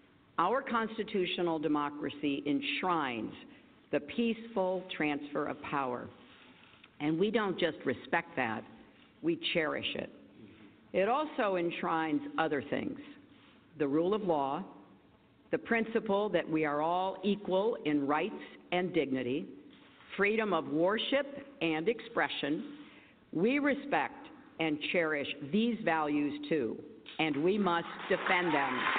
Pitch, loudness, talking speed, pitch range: 175 Hz, -33 LUFS, 115 wpm, 150-225 Hz